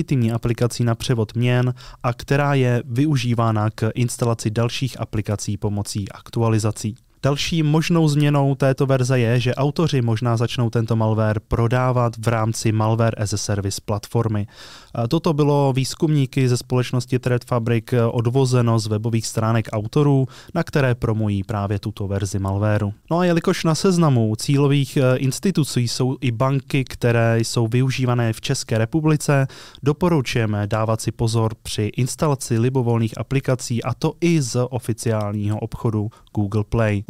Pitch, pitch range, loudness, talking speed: 120 Hz, 110-135 Hz, -20 LUFS, 135 wpm